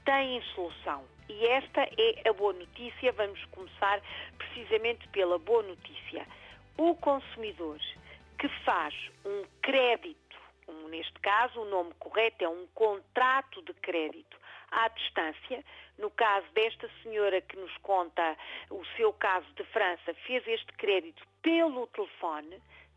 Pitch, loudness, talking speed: 225 Hz, -31 LUFS, 130 wpm